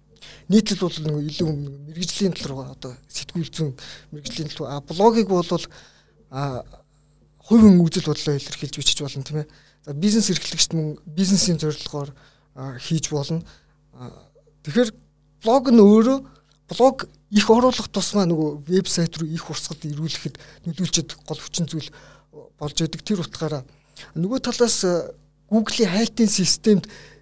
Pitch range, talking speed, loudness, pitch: 150-195 Hz, 125 wpm, -21 LUFS, 160 Hz